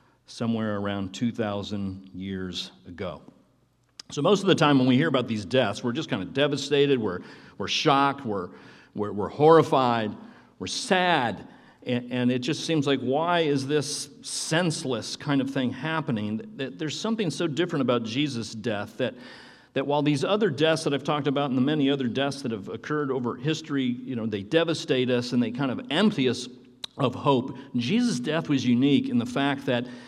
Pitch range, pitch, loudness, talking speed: 120-150 Hz, 135 Hz, -26 LUFS, 185 wpm